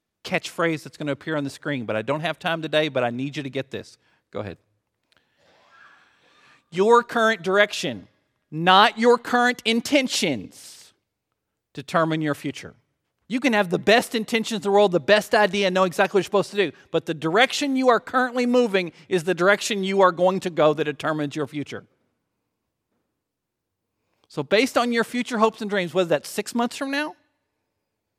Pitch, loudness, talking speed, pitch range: 190 Hz, -22 LUFS, 180 wpm, 150-230 Hz